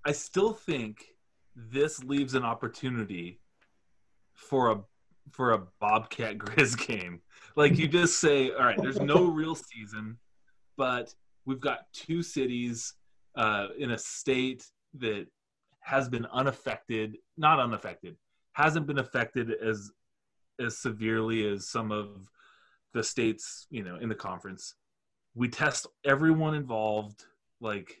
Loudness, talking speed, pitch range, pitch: -29 LUFS, 130 wpm, 110-145 Hz, 125 Hz